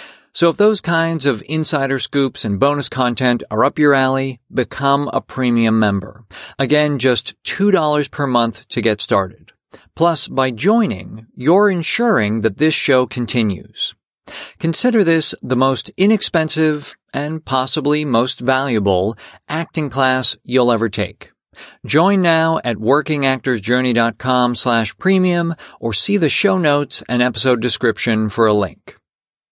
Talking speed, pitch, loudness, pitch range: 135 wpm, 135 Hz, -16 LUFS, 115-155 Hz